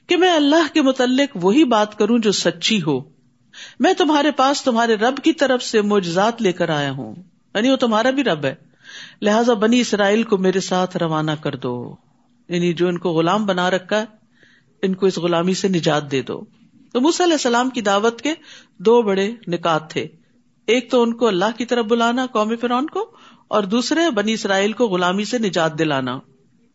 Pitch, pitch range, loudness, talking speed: 215 Hz, 180-250 Hz, -18 LUFS, 195 wpm